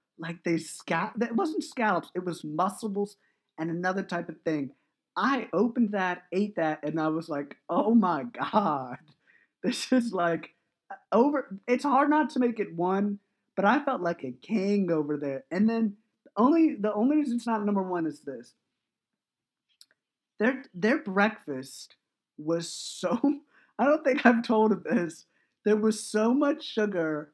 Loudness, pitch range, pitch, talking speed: -28 LUFS, 170-235 Hz, 205 Hz, 160 wpm